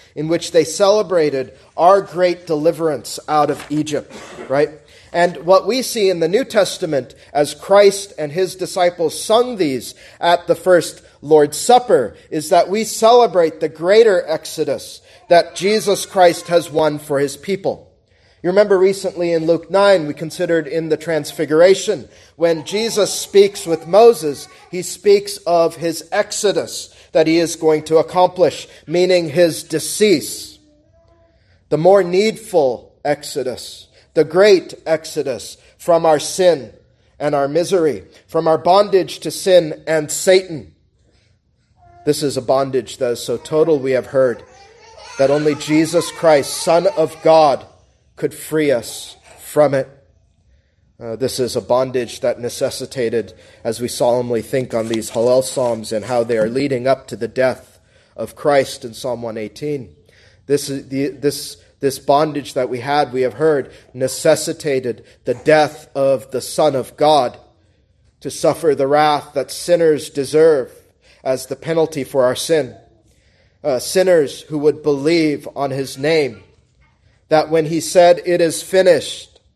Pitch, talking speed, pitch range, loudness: 155 Hz, 145 wpm, 130-175 Hz, -16 LUFS